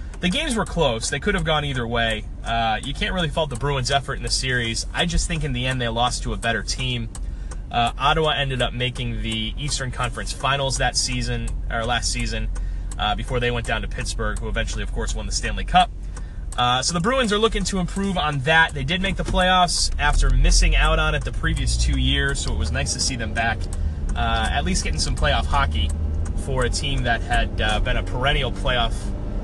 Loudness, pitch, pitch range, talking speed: -22 LUFS, 115 Hz, 95-135 Hz, 225 wpm